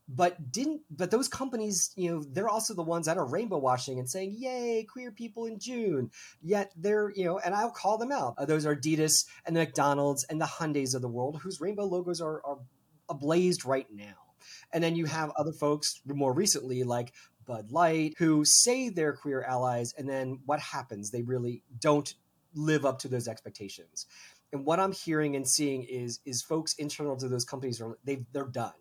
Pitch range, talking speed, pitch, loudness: 130-175 Hz, 200 wpm, 150 Hz, -30 LUFS